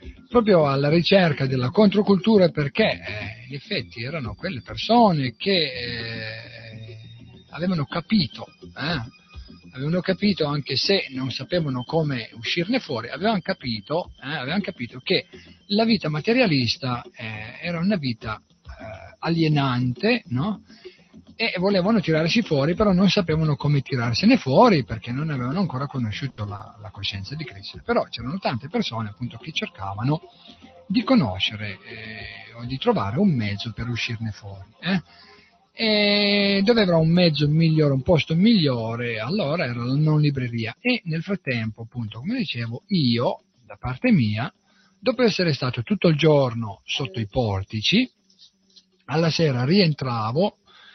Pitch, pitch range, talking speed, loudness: 145 Hz, 120-195 Hz, 140 wpm, -22 LUFS